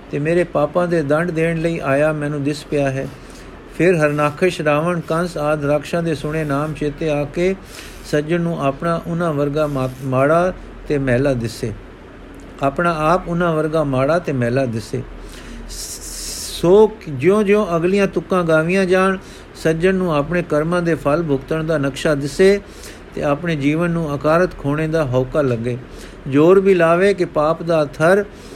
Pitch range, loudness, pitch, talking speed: 140-175 Hz, -18 LUFS, 155 Hz, 155 wpm